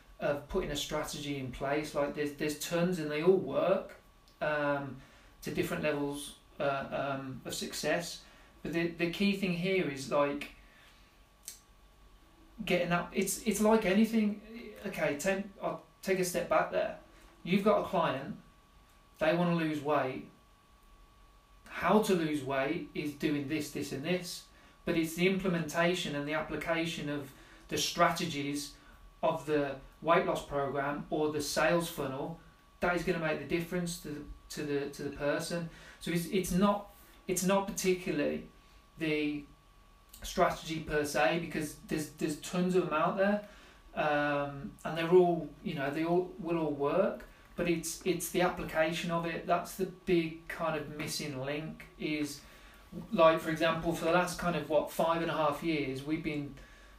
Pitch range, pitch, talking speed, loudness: 145-175 Hz, 160 Hz, 165 wpm, -33 LUFS